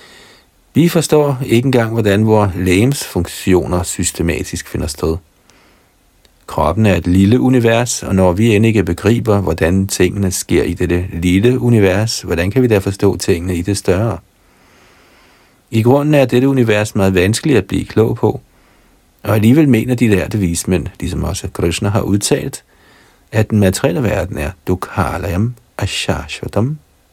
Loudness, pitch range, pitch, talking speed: -14 LUFS, 90-120 Hz, 100 Hz, 150 wpm